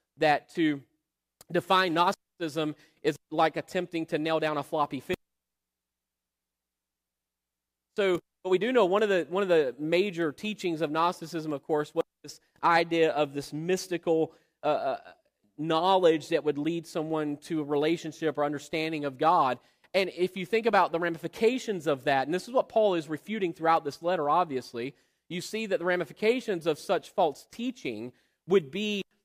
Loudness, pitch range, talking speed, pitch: -28 LUFS, 145-180 Hz, 165 wpm, 160 Hz